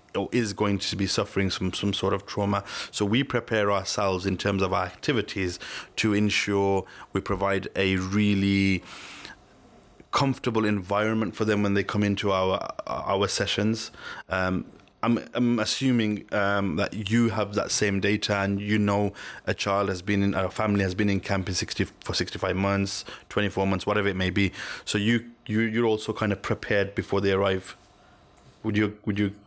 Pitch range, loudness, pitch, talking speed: 95-110 Hz, -26 LUFS, 100 Hz, 180 wpm